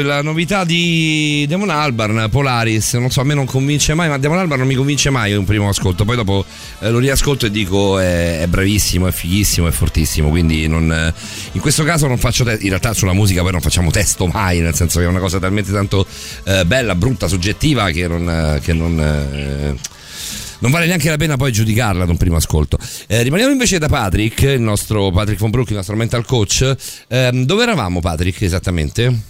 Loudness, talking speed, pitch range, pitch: -15 LUFS, 210 wpm, 90-130 Hz, 105 Hz